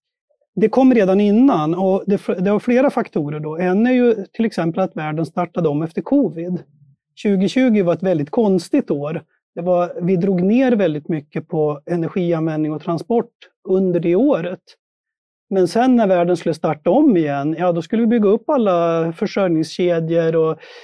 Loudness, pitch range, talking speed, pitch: -17 LUFS, 165-225 Hz, 165 wpm, 180 Hz